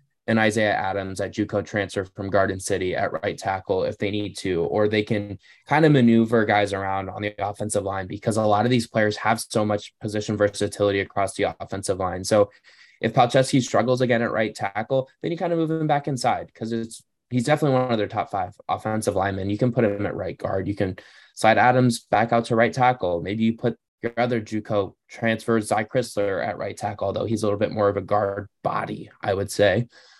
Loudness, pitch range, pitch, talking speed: -23 LUFS, 100-120 Hz, 110 Hz, 220 wpm